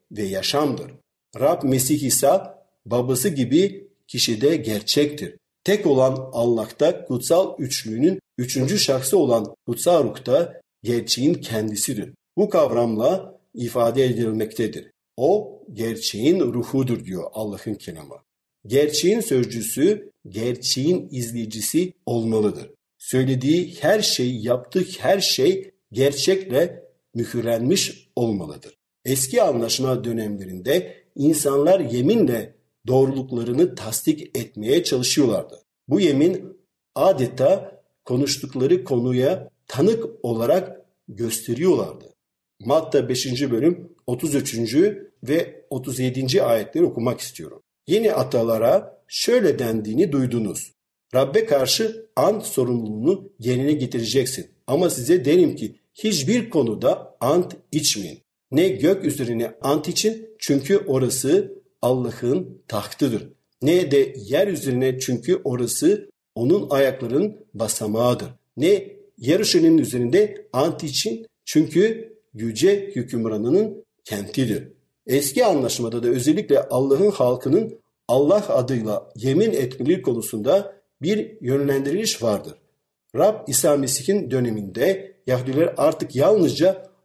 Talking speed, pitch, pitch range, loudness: 95 wpm, 135 Hz, 120-190 Hz, -21 LUFS